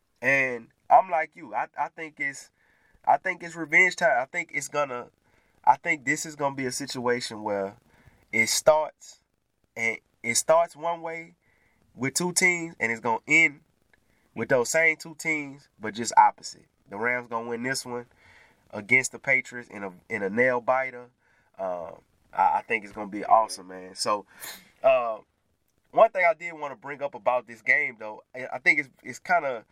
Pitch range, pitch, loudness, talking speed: 115-165 Hz, 130 Hz, -25 LUFS, 185 wpm